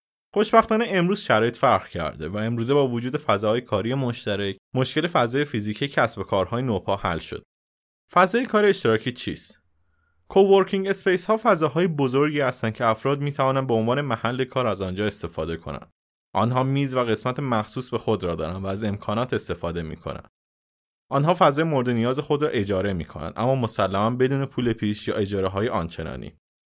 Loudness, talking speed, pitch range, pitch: -23 LUFS, 170 wpm, 105-145 Hz, 120 Hz